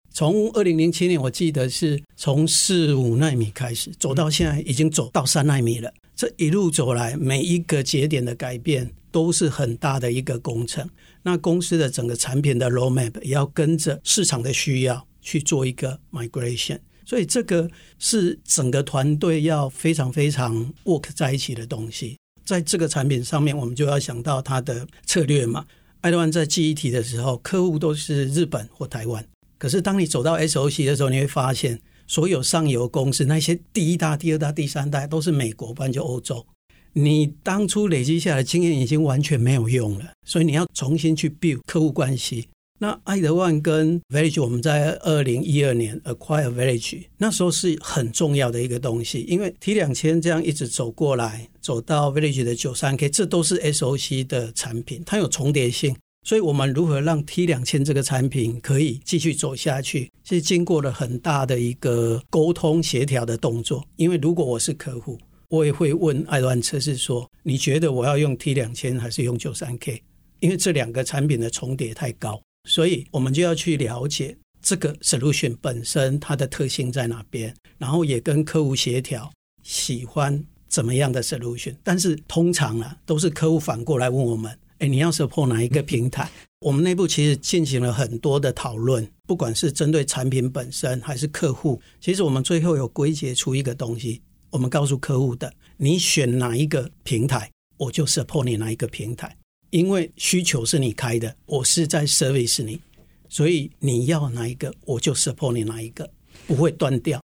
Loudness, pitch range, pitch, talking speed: -22 LUFS, 125-160 Hz, 145 Hz, 325 characters per minute